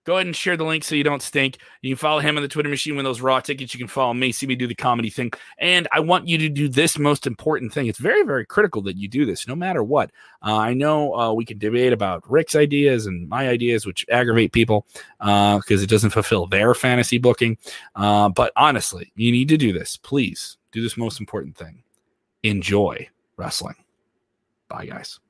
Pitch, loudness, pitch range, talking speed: 125 Hz, -20 LUFS, 110-145 Hz, 225 wpm